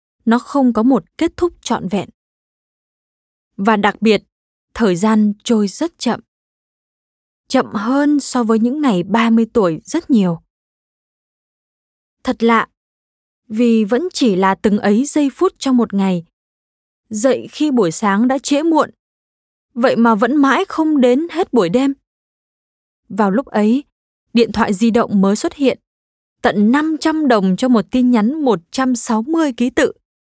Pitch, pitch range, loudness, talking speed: 235 Hz, 210-270 Hz, -15 LUFS, 150 wpm